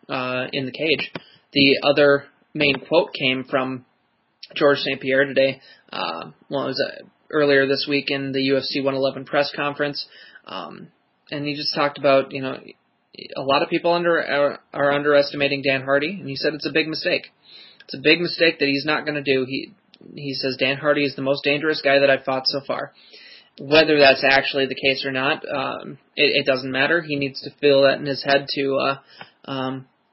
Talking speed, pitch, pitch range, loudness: 200 wpm, 140 Hz, 135-145 Hz, -20 LUFS